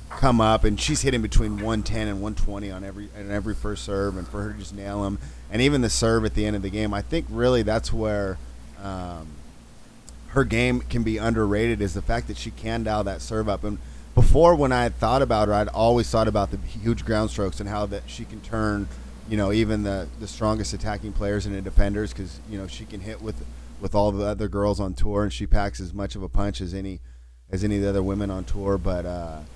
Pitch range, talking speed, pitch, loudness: 100-110 Hz, 240 wpm, 105 Hz, -25 LUFS